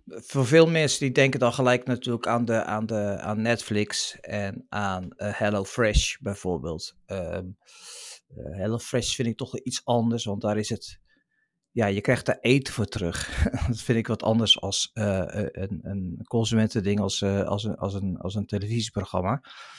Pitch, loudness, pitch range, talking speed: 110 Hz, -26 LUFS, 100-120 Hz, 175 wpm